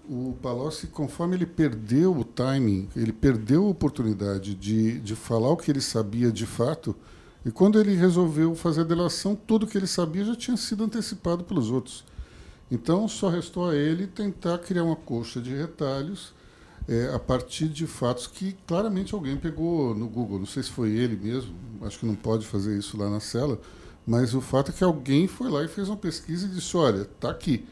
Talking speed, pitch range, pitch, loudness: 195 wpm, 115-175 Hz, 140 Hz, -26 LUFS